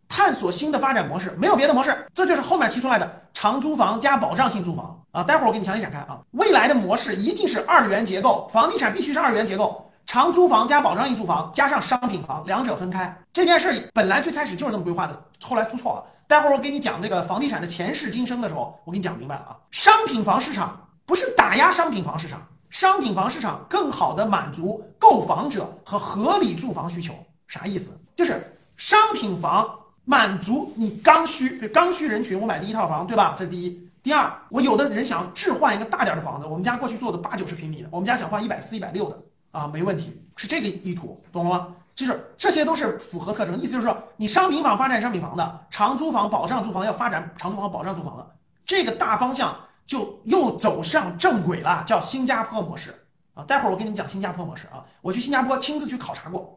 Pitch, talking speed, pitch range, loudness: 215 Hz, 355 characters per minute, 180-280 Hz, -20 LUFS